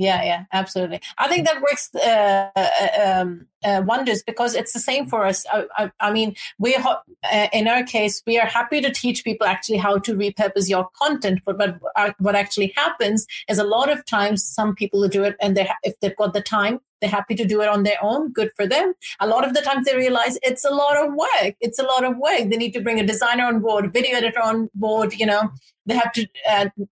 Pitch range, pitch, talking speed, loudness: 205-245 Hz, 220 Hz, 245 wpm, -20 LUFS